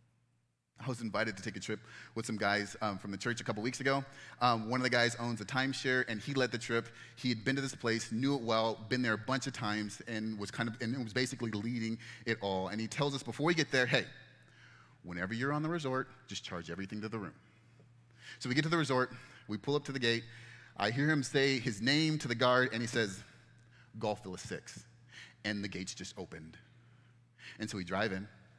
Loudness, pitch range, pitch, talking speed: -35 LUFS, 110-130 Hz, 120 Hz, 235 wpm